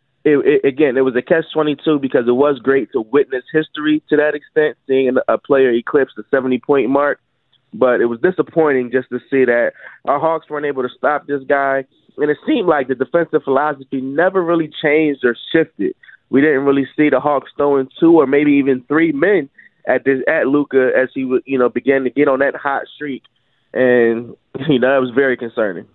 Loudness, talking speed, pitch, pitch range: -16 LUFS, 205 wpm, 140 Hz, 130-150 Hz